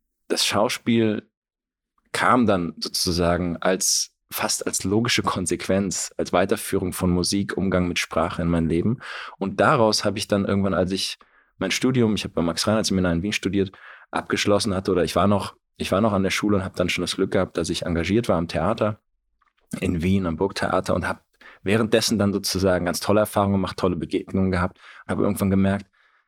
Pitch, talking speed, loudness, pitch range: 95 Hz, 190 wpm, -22 LUFS, 90-105 Hz